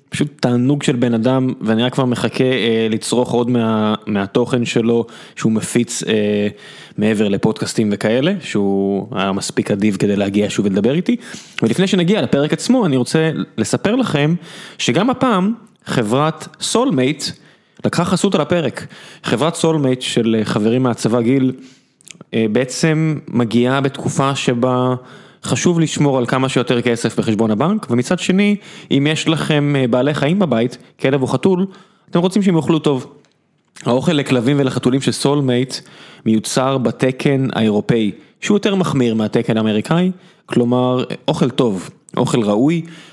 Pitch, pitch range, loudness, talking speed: 130 Hz, 120-165 Hz, -17 LUFS, 140 wpm